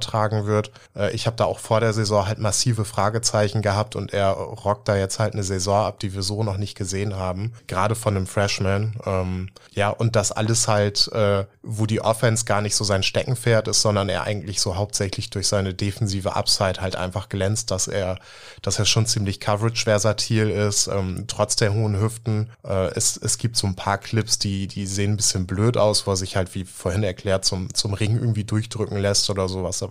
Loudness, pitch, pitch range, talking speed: -22 LUFS, 105 Hz, 100-110 Hz, 215 wpm